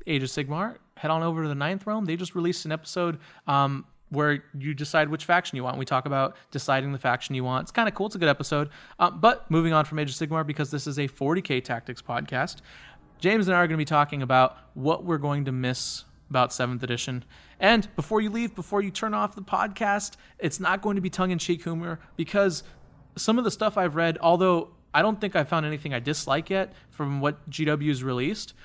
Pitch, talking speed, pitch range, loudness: 155 Hz, 230 wpm, 140-185 Hz, -26 LUFS